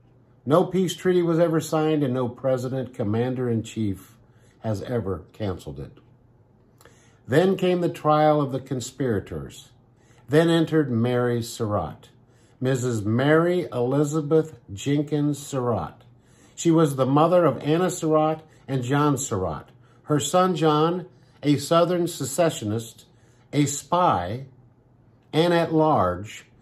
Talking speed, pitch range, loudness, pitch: 120 wpm, 120-155 Hz, -23 LUFS, 130 Hz